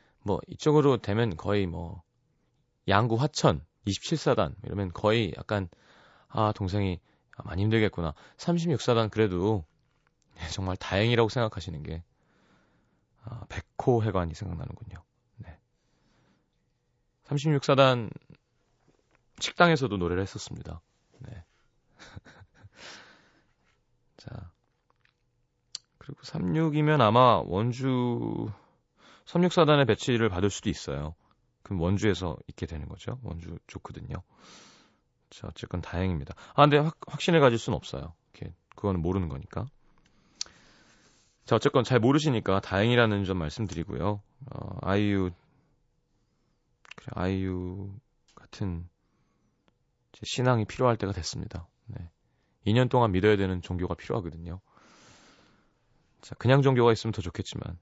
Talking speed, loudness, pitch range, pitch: 240 characters per minute, -27 LUFS, 90-125 Hz, 105 Hz